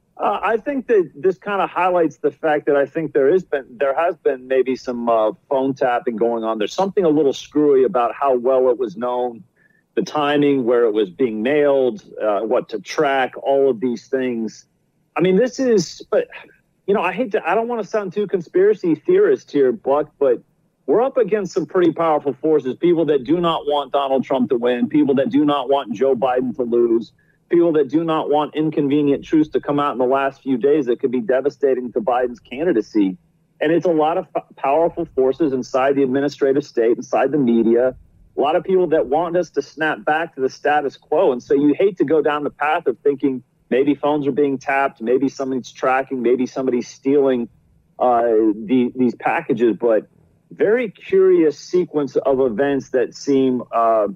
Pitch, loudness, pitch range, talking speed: 145 Hz, -18 LUFS, 130-170 Hz, 205 wpm